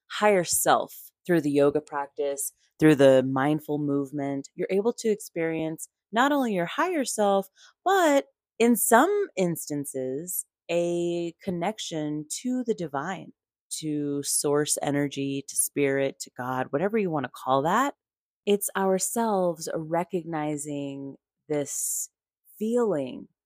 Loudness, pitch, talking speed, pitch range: -26 LUFS, 165 Hz, 120 wpm, 145-205 Hz